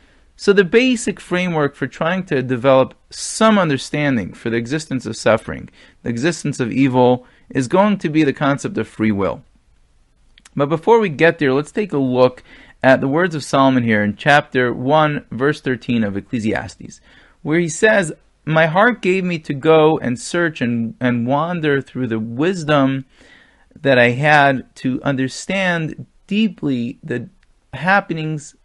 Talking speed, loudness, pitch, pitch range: 155 wpm, -17 LUFS, 140 Hz, 125-170 Hz